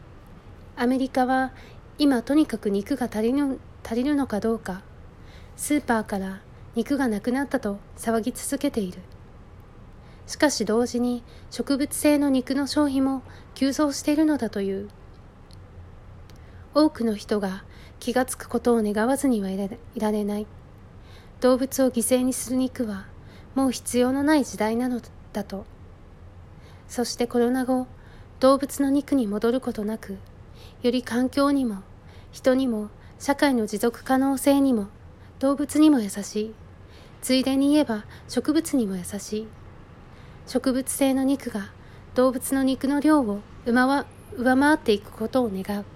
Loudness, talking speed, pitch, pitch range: -24 LUFS, 255 characters per minute, 240 Hz, 205-270 Hz